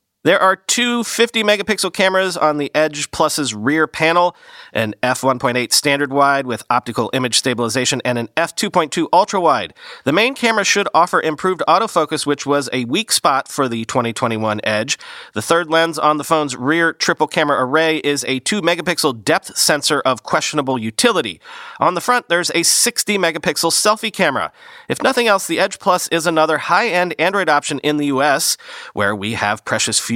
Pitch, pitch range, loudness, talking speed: 155 Hz, 130-180 Hz, -16 LUFS, 175 wpm